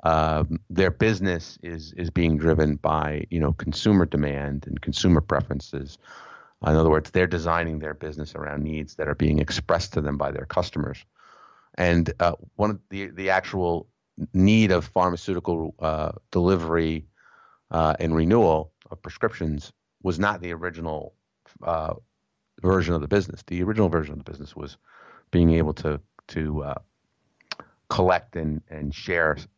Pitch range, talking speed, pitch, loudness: 75-90 Hz, 150 wpm, 80 Hz, -24 LUFS